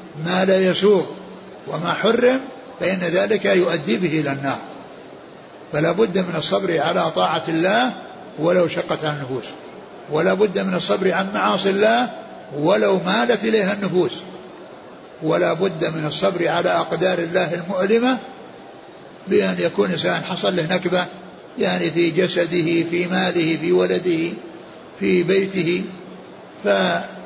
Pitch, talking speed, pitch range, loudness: 180 Hz, 125 wpm, 170-195 Hz, -19 LUFS